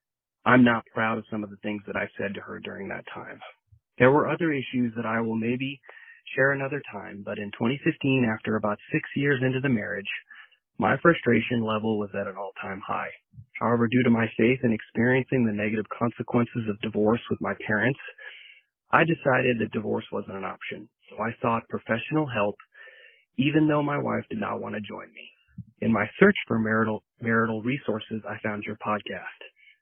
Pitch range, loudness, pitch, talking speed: 105-130 Hz, -26 LUFS, 115 Hz, 185 wpm